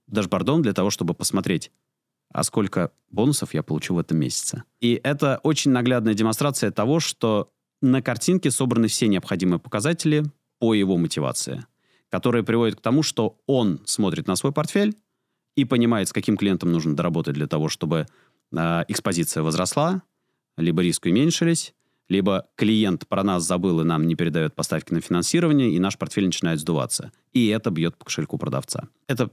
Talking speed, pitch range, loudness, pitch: 160 wpm, 90-140 Hz, -23 LUFS, 110 Hz